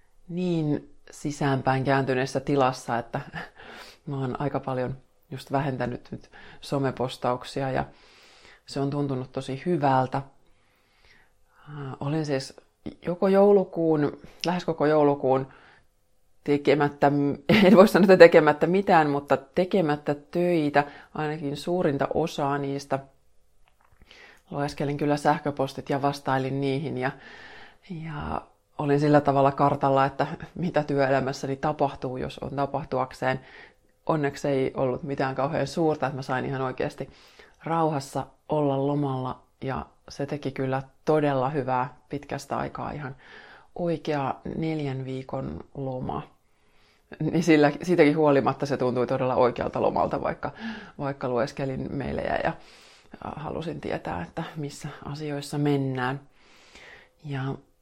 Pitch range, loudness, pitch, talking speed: 130-150 Hz, -25 LUFS, 140 Hz, 110 wpm